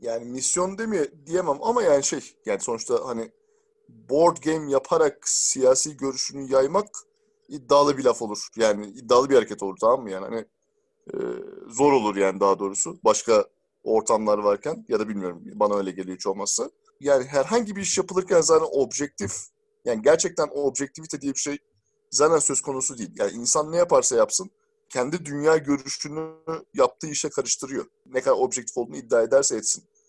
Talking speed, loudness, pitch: 160 wpm, -23 LUFS, 160 Hz